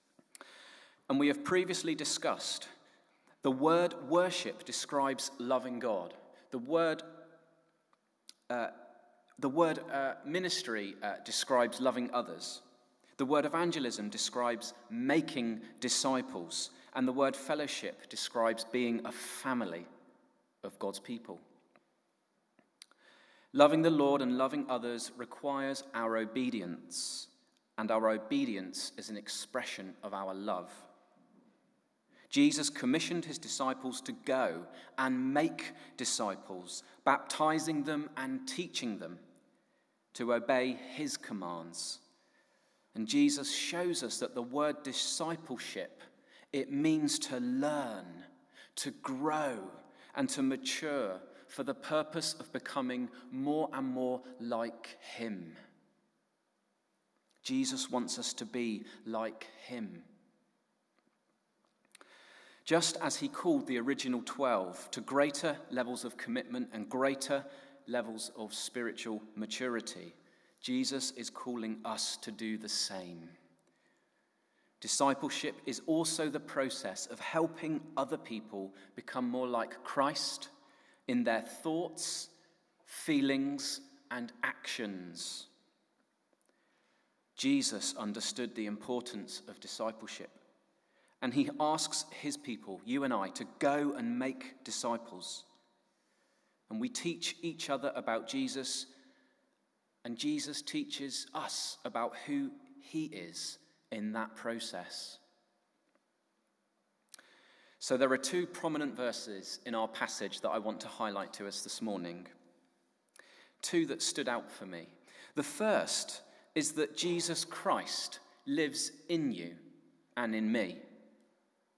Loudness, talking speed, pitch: -35 LUFS, 110 wpm, 145 Hz